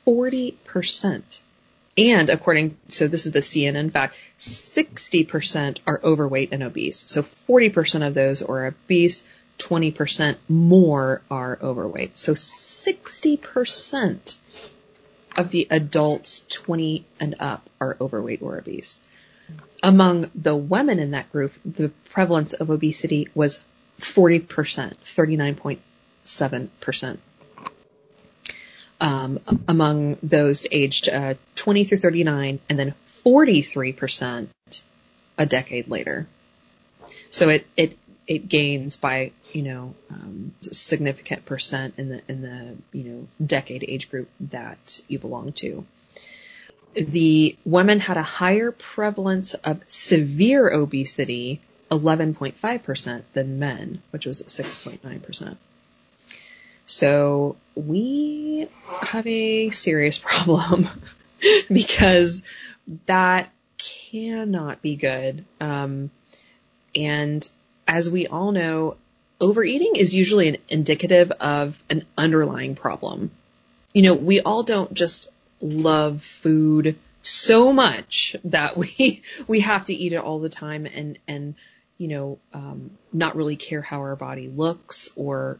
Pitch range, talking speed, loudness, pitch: 140-180 Hz, 120 wpm, -21 LUFS, 155 Hz